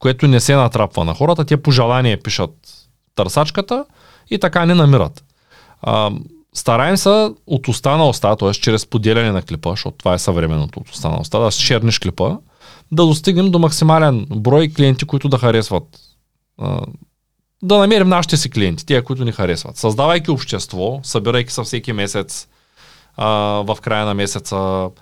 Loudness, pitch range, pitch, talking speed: -16 LUFS, 105-155 Hz, 125 Hz, 155 wpm